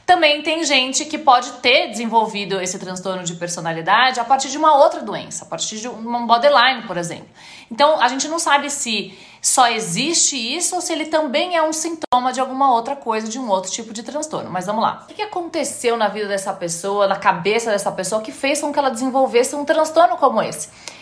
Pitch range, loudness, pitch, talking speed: 210-300 Hz, -18 LUFS, 255 Hz, 210 wpm